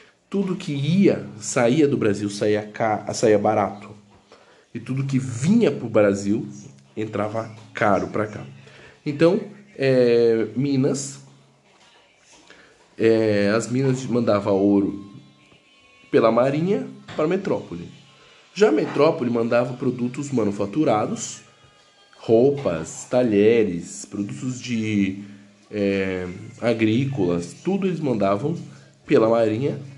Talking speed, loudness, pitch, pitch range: 100 wpm, -21 LUFS, 115 Hz, 105-135 Hz